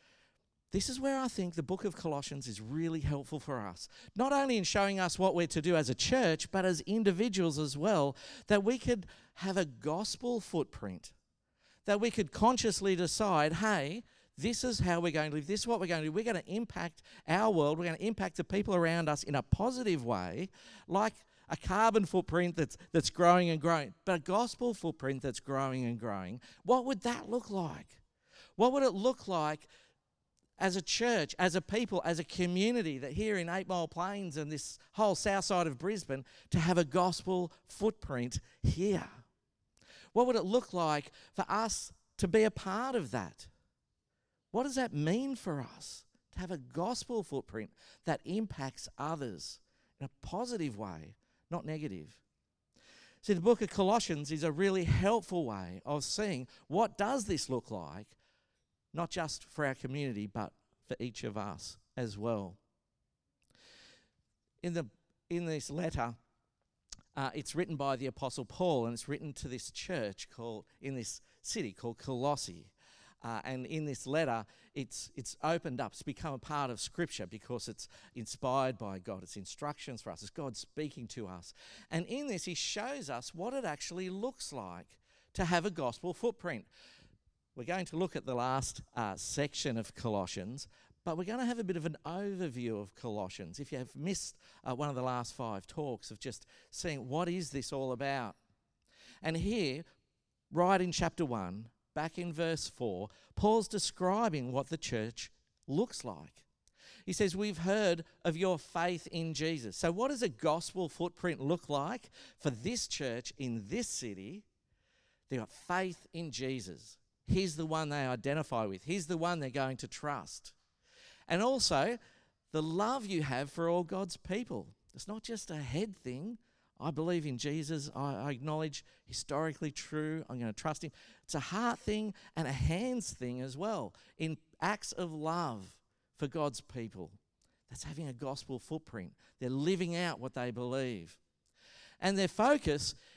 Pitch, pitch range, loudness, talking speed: 160 Hz, 130-190 Hz, -36 LUFS, 175 wpm